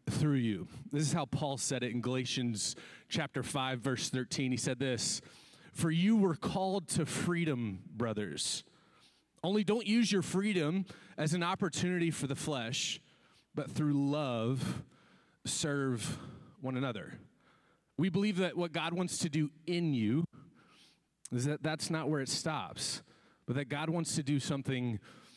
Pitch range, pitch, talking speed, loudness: 130-175 Hz, 150 Hz, 155 wpm, -35 LUFS